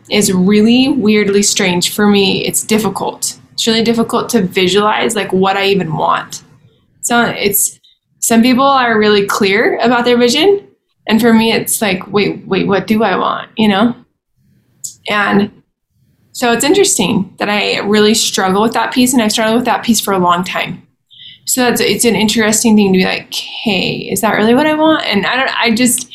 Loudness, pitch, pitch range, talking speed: -12 LUFS, 215 Hz, 200-235 Hz, 190 wpm